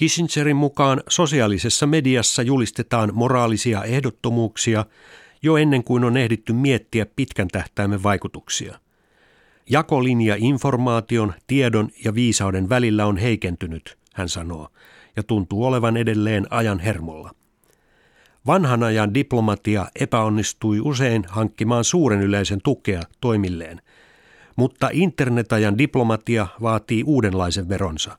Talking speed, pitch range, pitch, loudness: 100 wpm, 105-130 Hz, 115 Hz, -20 LUFS